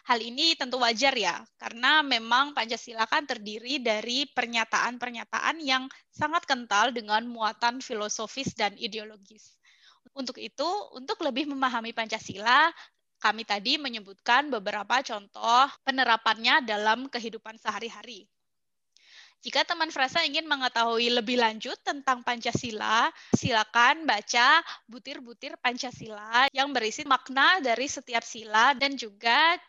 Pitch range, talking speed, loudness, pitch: 225-275 Hz, 115 wpm, -26 LUFS, 245 Hz